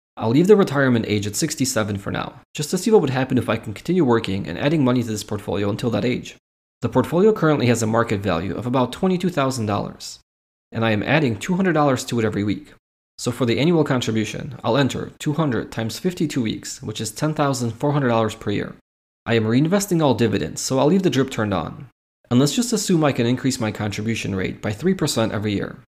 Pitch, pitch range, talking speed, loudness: 125 Hz, 110-150 Hz, 210 wpm, -21 LUFS